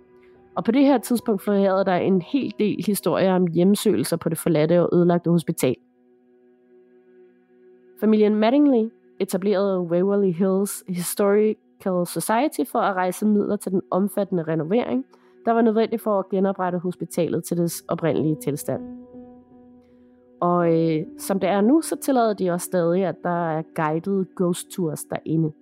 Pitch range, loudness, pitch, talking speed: 160-210 Hz, -22 LUFS, 180 Hz, 150 wpm